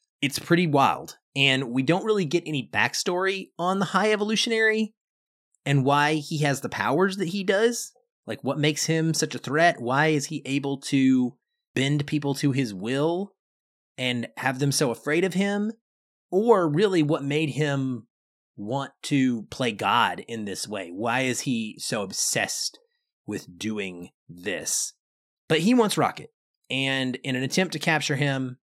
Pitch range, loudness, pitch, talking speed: 130-185 Hz, -25 LUFS, 150 Hz, 165 wpm